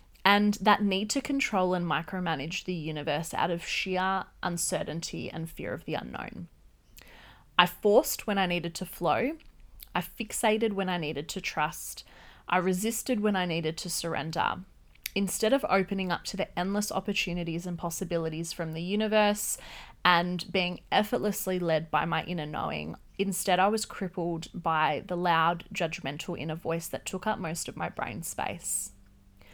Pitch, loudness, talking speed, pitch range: 180 Hz, -29 LUFS, 160 wpm, 165-195 Hz